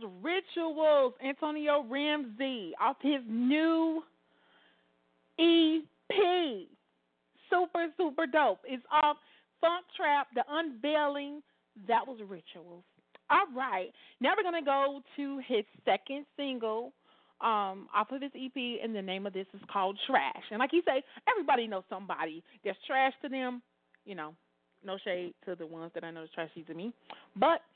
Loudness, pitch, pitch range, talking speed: -32 LUFS, 265 Hz, 195-300 Hz, 145 wpm